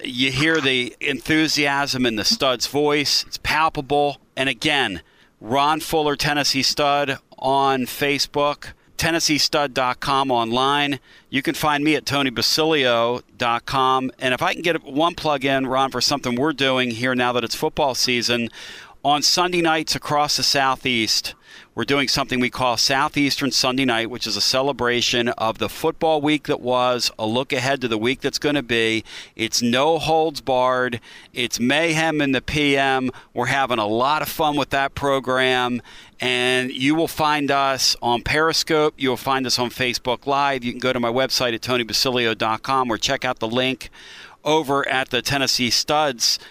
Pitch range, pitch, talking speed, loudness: 125-145 Hz, 135 Hz, 165 wpm, -20 LUFS